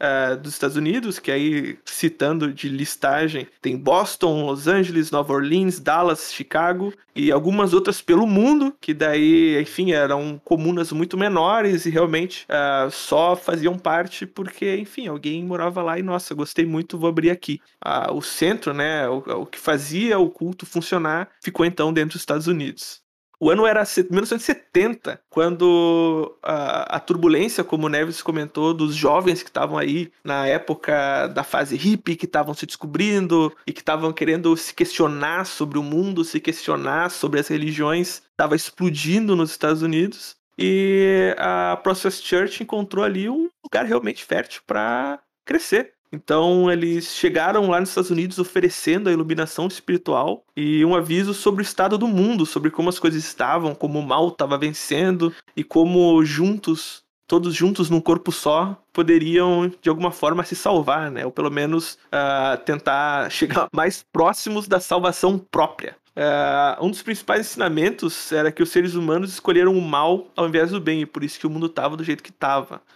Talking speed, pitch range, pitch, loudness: 165 wpm, 155-185 Hz, 170 Hz, -21 LUFS